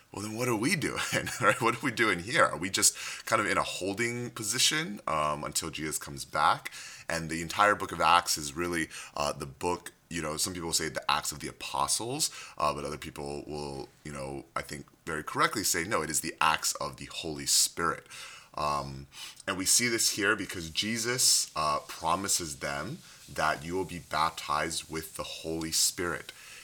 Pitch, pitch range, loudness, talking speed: 80 Hz, 75-100 Hz, -29 LUFS, 195 wpm